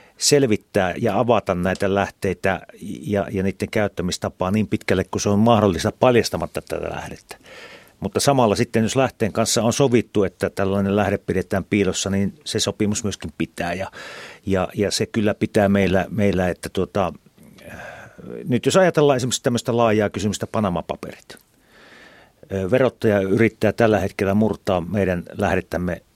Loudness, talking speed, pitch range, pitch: -20 LUFS, 140 wpm, 95-115 Hz, 105 Hz